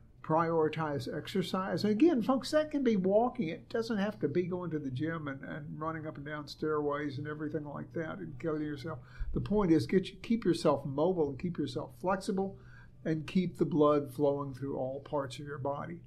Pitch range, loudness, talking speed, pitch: 145-185 Hz, -33 LUFS, 200 wpm, 160 Hz